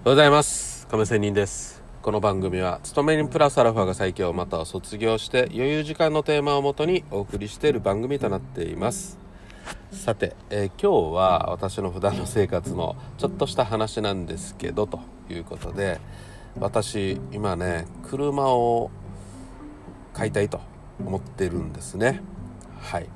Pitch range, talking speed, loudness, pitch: 95-130 Hz, 315 characters per minute, -24 LUFS, 105 Hz